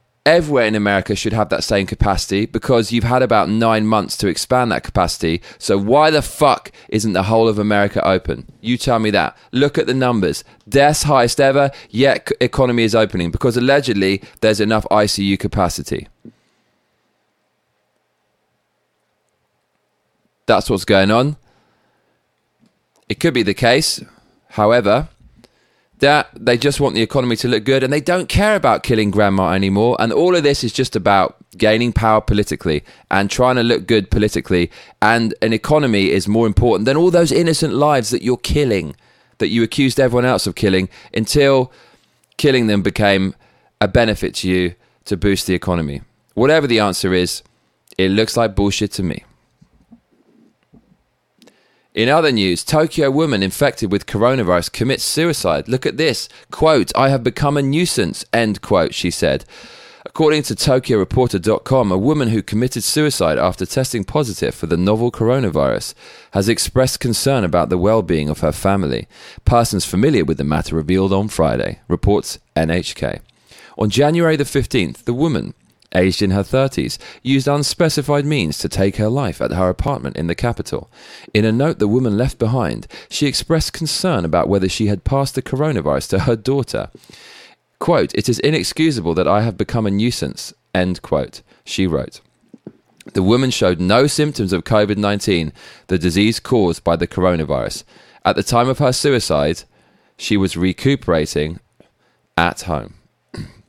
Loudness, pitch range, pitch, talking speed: -16 LUFS, 95-130 Hz, 110 Hz, 160 wpm